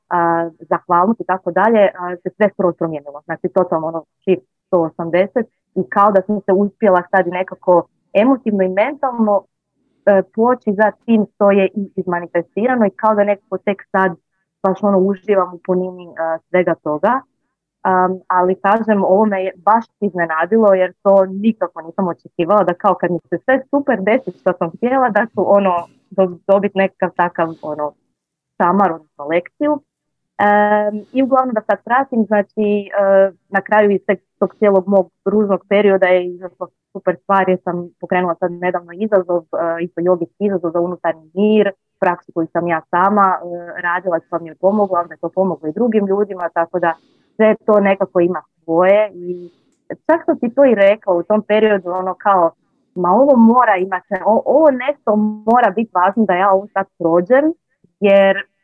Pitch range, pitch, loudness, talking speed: 175-210 Hz, 190 Hz, -16 LUFS, 170 wpm